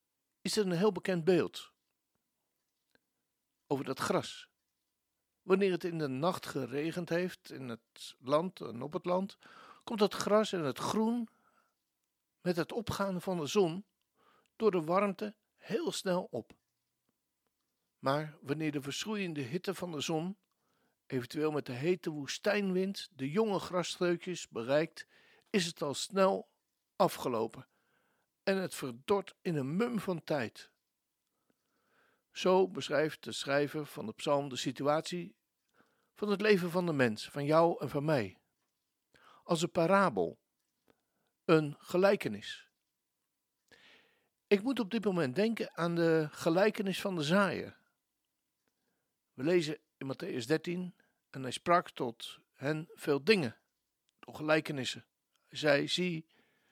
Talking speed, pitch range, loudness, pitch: 130 wpm, 150-195 Hz, -33 LUFS, 175 Hz